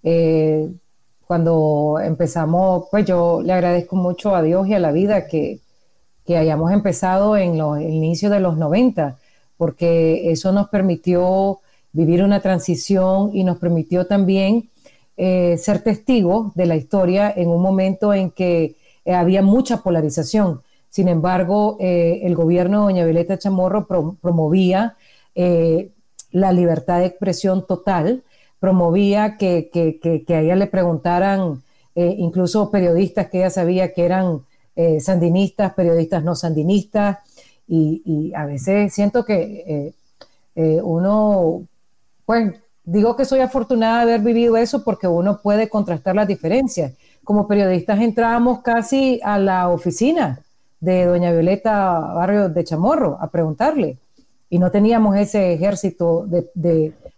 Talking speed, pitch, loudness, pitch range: 140 wpm, 185 Hz, -18 LUFS, 170-205 Hz